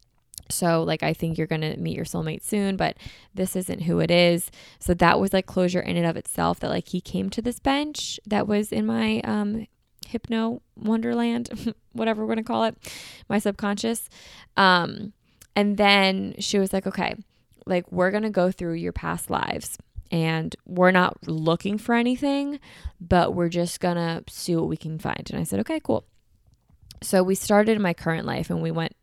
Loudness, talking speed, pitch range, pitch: -24 LUFS, 195 wpm, 170-215 Hz, 185 Hz